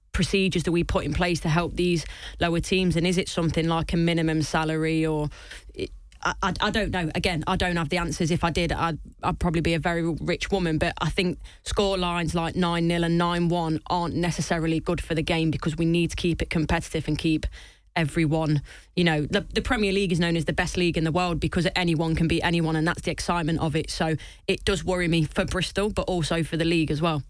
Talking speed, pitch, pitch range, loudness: 235 wpm, 170 Hz, 160-180 Hz, -25 LUFS